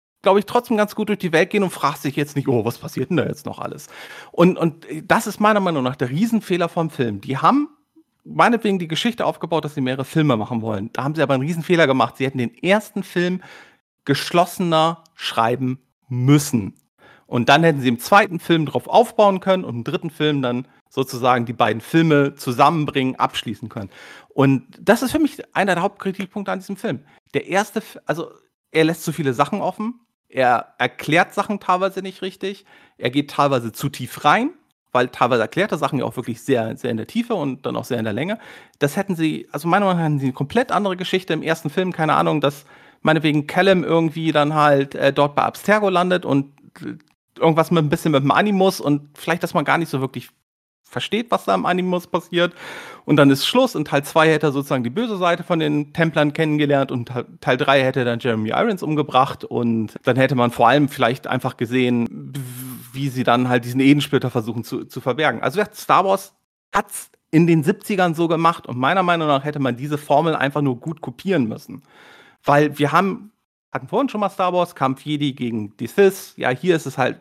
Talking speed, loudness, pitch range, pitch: 210 wpm, -19 LUFS, 135-180 Hz, 150 Hz